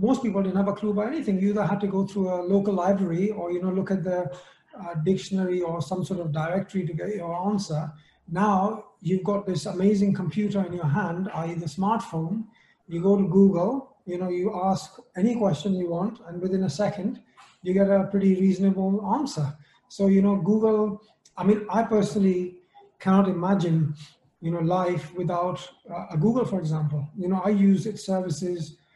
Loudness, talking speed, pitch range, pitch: -25 LUFS, 195 wpm, 175-205 Hz, 190 Hz